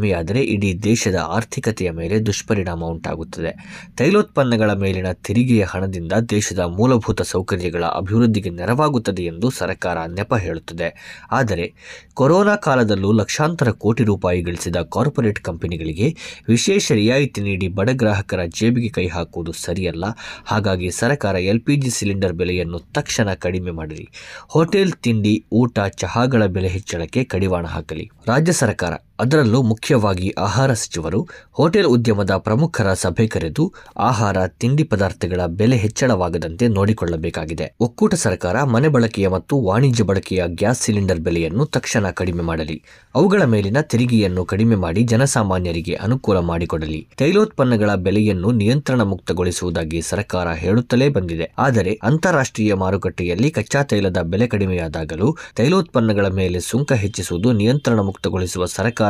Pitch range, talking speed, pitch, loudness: 90-120 Hz, 115 wpm, 105 Hz, -19 LUFS